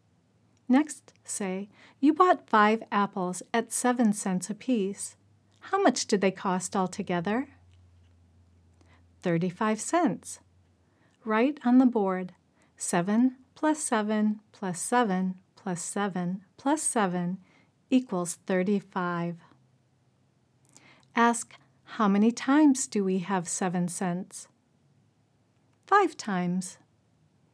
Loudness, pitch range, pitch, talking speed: -27 LUFS, 170-235 Hz, 190 Hz, 100 wpm